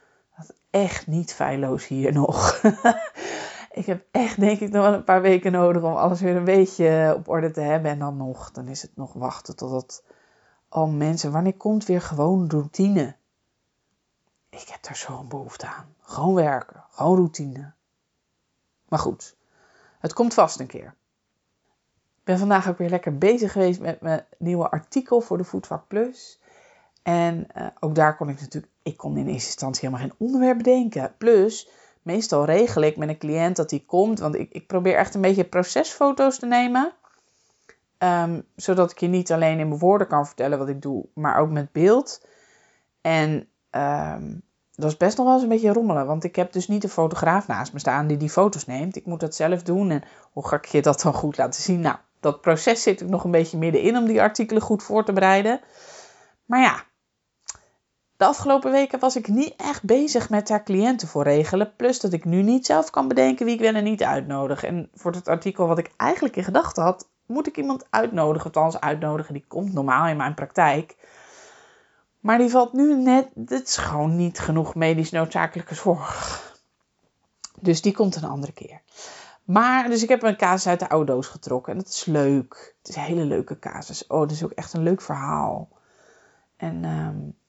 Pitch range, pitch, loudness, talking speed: 155-210 Hz, 175 Hz, -22 LUFS, 195 wpm